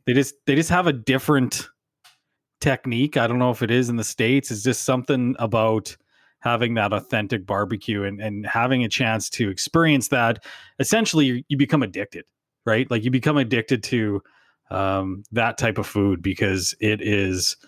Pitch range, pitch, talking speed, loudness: 105-135 Hz, 120 Hz, 175 wpm, -22 LUFS